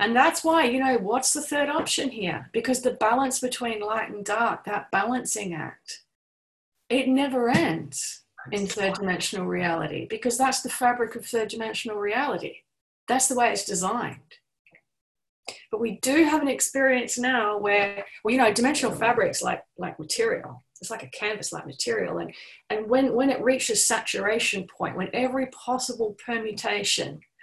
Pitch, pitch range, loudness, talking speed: 240 Hz, 210-260 Hz, -25 LUFS, 160 wpm